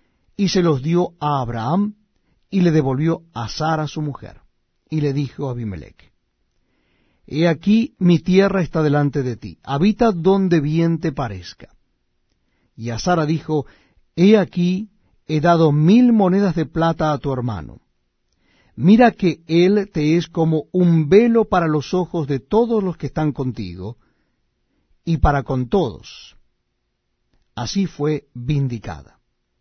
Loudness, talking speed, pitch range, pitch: -18 LUFS, 140 wpm, 135-180 Hz, 160 Hz